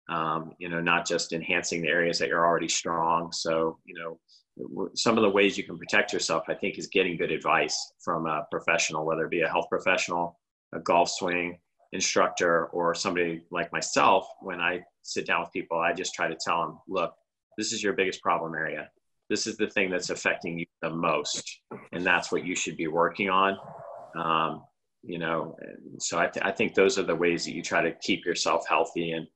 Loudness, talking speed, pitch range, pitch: -27 LUFS, 210 wpm, 85-95 Hz, 85 Hz